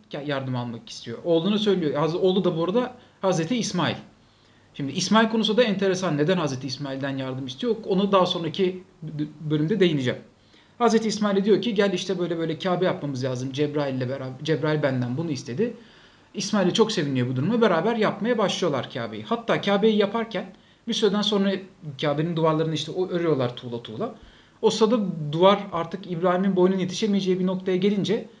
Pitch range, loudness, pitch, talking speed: 145-200 Hz, -24 LUFS, 180 Hz, 155 wpm